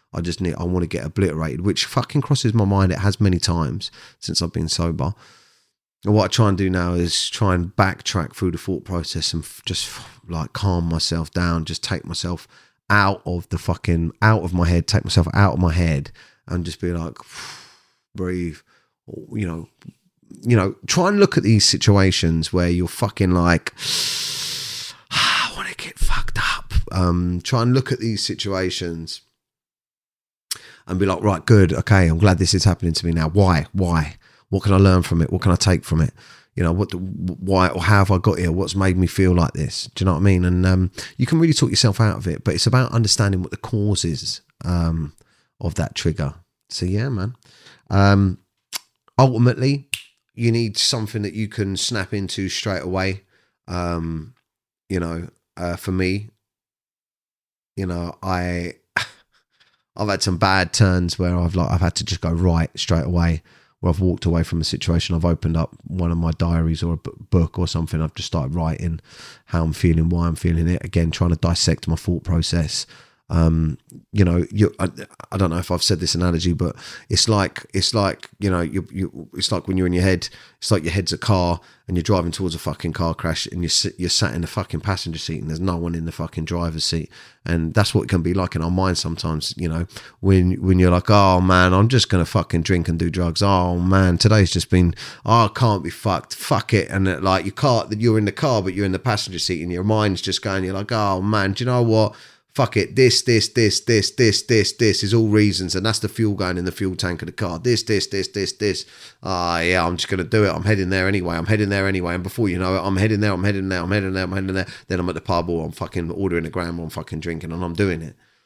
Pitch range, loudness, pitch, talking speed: 85-105 Hz, -20 LUFS, 95 Hz, 230 wpm